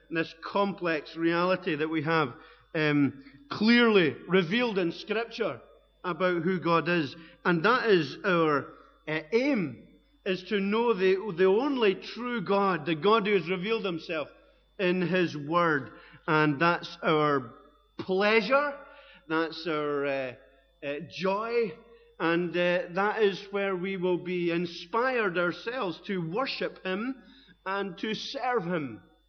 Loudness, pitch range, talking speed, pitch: -28 LUFS, 165-215 Hz, 130 wpm, 180 Hz